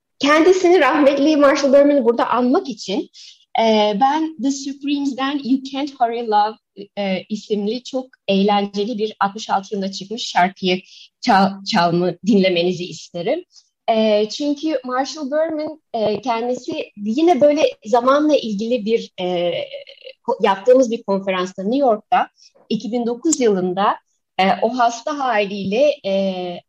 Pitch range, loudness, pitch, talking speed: 200-280 Hz, -18 LUFS, 235 Hz, 115 wpm